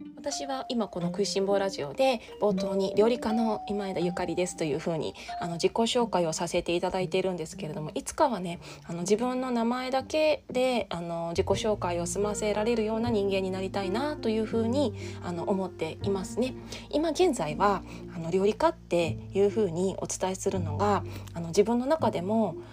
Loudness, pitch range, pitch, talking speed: -29 LUFS, 175-230 Hz, 195 Hz, 380 characters per minute